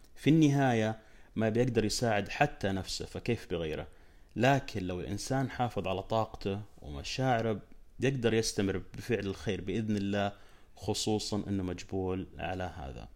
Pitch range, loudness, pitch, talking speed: 95-115 Hz, -32 LUFS, 100 Hz, 125 wpm